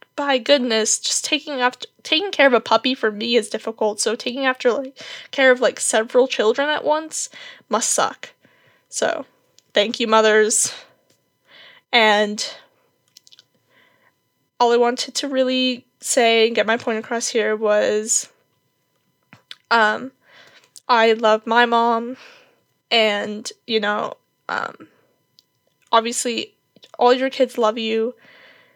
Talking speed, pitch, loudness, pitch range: 125 wpm, 240 Hz, -19 LUFS, 225-275 Hz